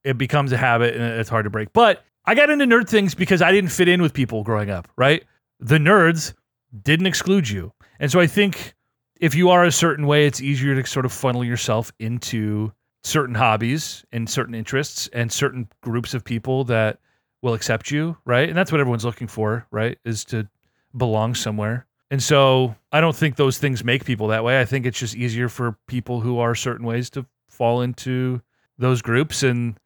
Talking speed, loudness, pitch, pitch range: 205 wpm, -20 LUFS, 125 Hz, 115-145 Hz